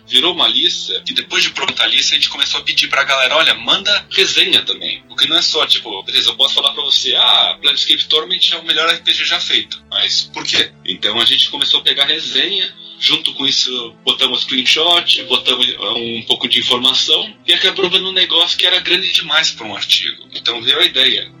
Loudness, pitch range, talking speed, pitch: -12 LUFS, 125-180 Hz, 215 wpm, 135 Hz